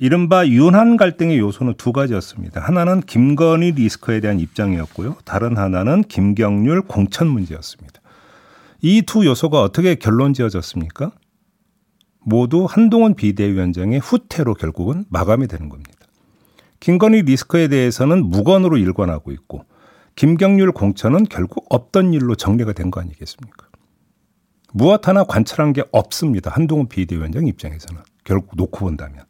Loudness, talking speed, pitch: -16 LUFS, 345 characters per minute, 125 Hz